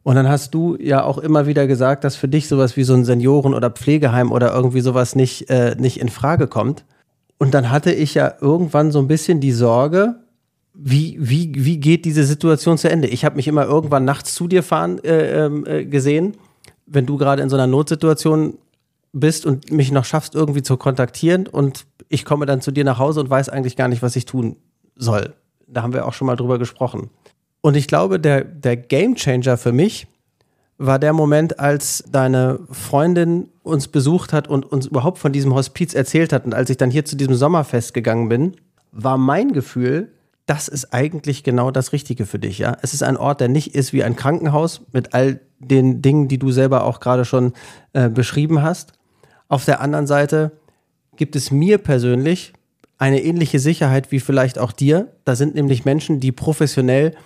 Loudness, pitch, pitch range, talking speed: -17 LUFS, 140 Hz, 130-155 Hz, 200 wpm